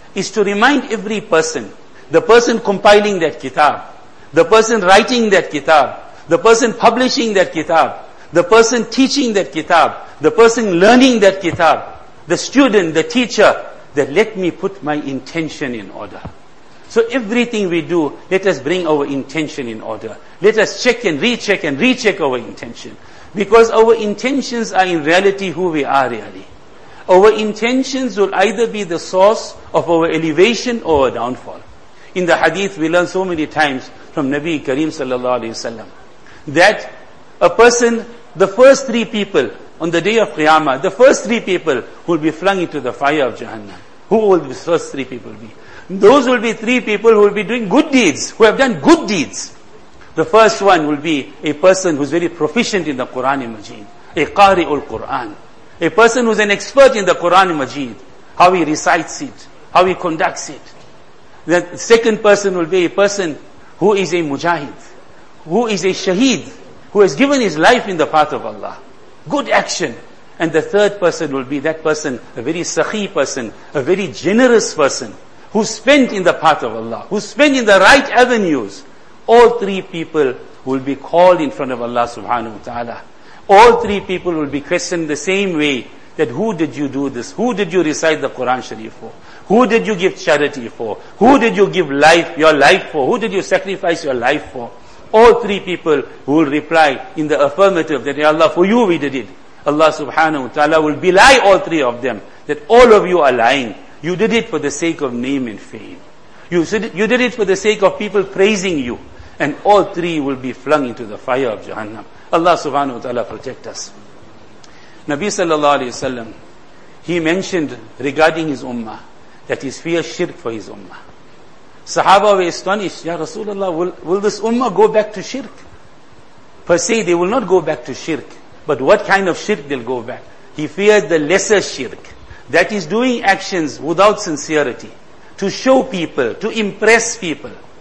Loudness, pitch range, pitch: -14 LUFS, 155-215 Hz, 180 Hz